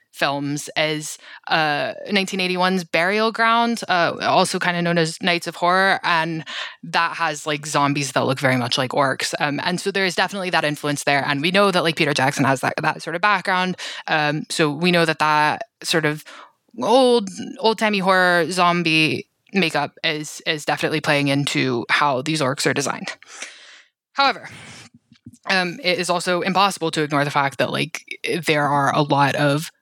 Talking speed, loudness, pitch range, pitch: 180 wpm, -19 LUFS, 145-185 Hz, 160 Hz